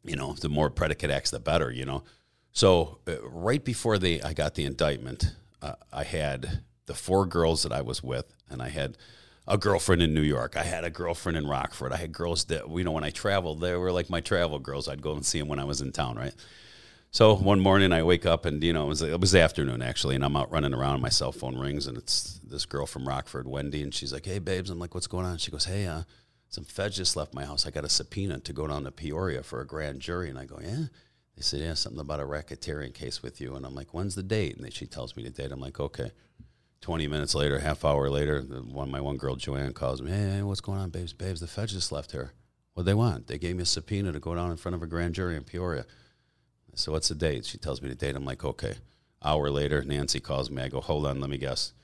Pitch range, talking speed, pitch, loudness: 70-90 Hz, 270 wpm, 75 Hz, -29 LUFS